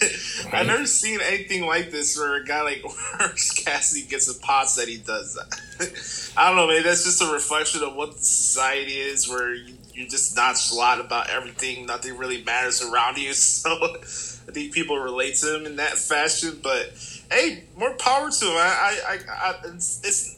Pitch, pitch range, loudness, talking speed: 150 Hz, 135-200 Hz, -22 LUFS, 195 wpm